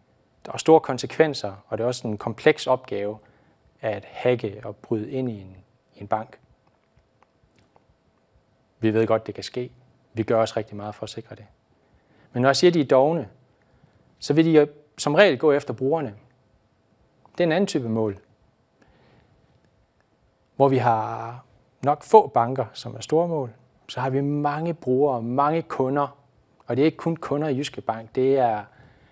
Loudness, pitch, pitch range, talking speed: -23 LUFS, 130 Hz, 110-145 Hz, 175 wpm